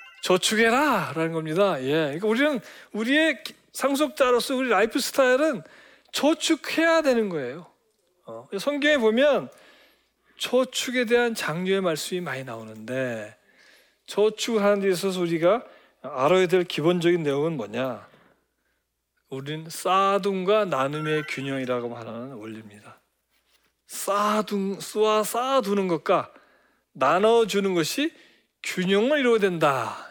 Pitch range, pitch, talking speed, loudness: 155-240 Hz, 195 Hz, 270 characters per minute, -23 LUFS